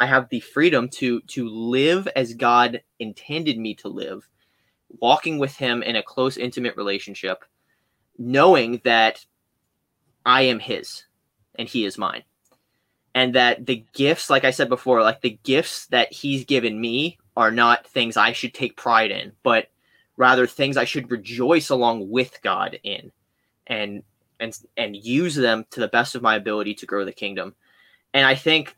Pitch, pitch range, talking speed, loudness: 120 Hz, 115-130 Hz, 170 wpm, -21 LUFS